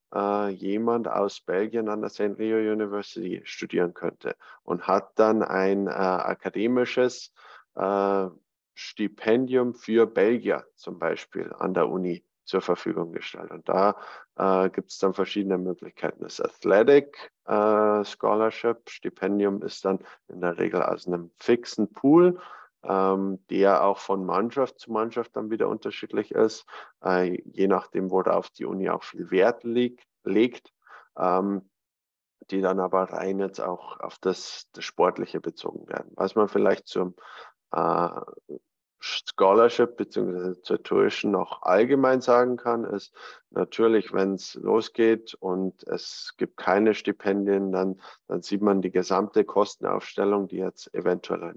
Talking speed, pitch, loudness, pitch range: 140 wpm, 100 Hz, -25 LUFS, 95-110 Hz